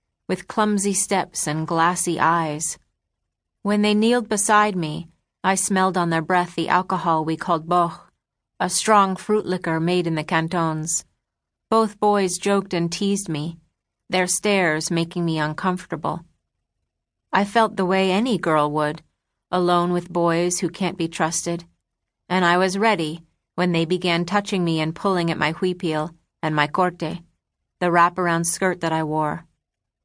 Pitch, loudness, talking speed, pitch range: 175 Hz, -21 LUFS, 155 wpm, 160-190 Hz